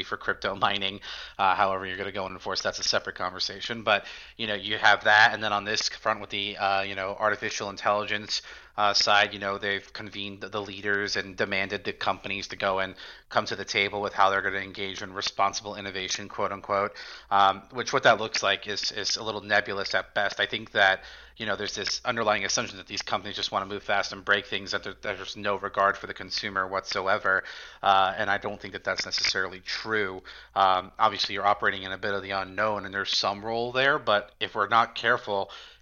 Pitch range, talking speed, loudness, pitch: 95-105 Hz, 225 wpm, -27 LUFS, 100 Hz